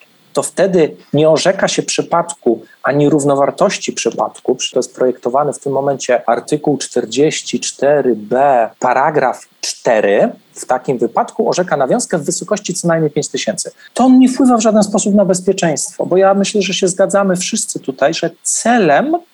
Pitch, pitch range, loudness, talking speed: 180 Hz, 145-210 Hz, -14 LUFS, 150 wpm